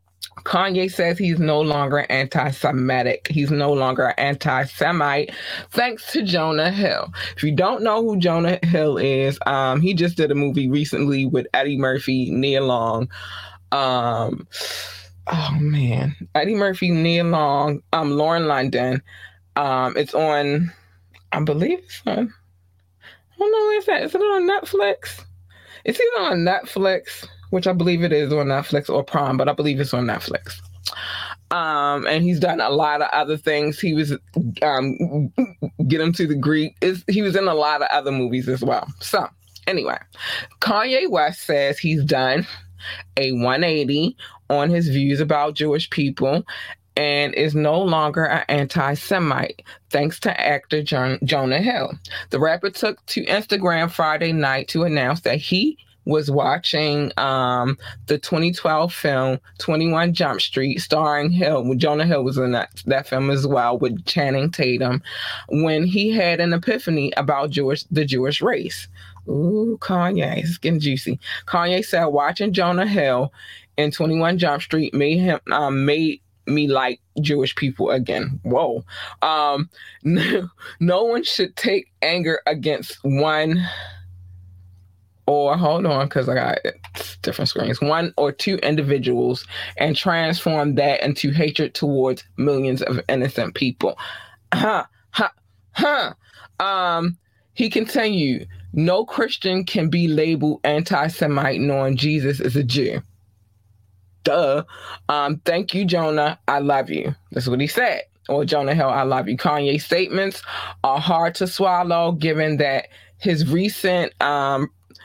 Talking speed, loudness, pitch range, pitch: 150 wpm, -20 LUFS, 130-170 Hz, 150 Hz